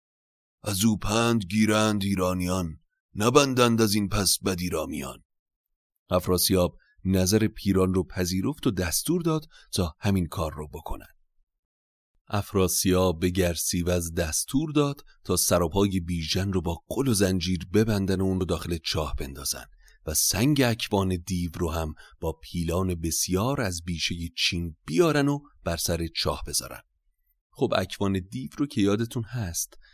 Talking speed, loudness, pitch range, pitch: 140 wpm, -26 LUFS, 85-105 Hz, 95 Hz